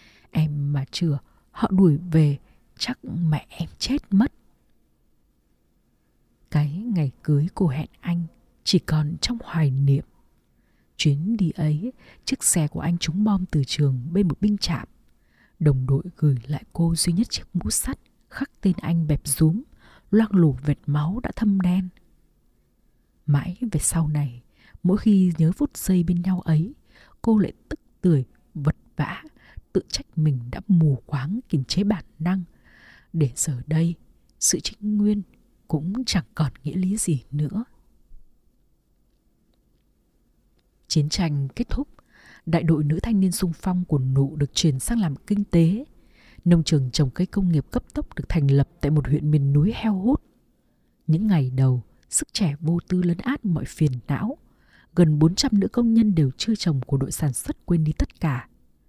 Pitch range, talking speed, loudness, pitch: 150-190 Hz, 170 wpm, -23 LUFS, 165 Hz